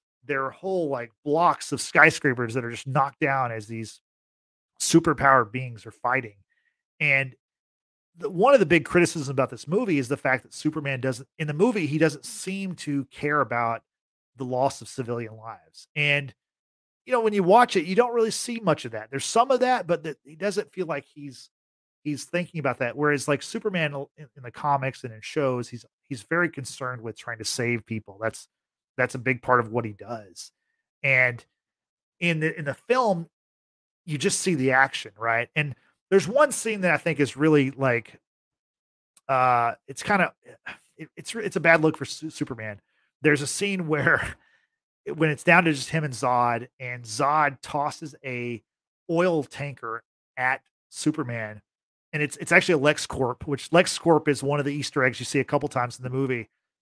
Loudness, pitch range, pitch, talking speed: -24 LUFS, 125-160 Hz, 140 Hz, 195 wpm